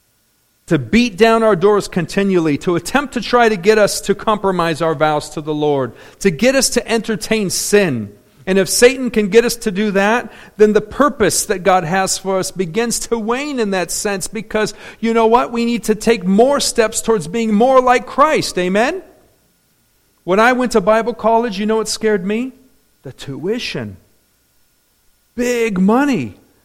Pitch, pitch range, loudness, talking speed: 215 Hz, 190-235 Hz, -15 LUFS, 180 wpm